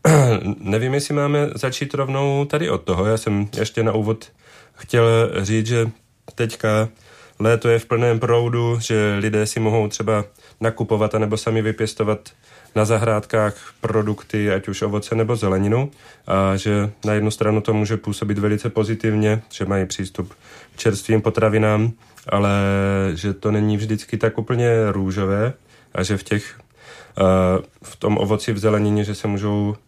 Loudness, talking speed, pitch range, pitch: -20 LUFS, 150 wpm, 105-115 Hz, 110 Hz